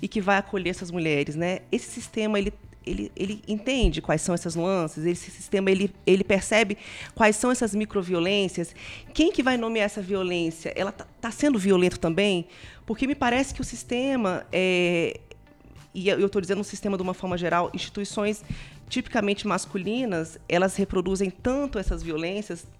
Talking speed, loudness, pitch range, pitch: 170 wpm, -26 LUFS, 180-215 Hz, 200 Hz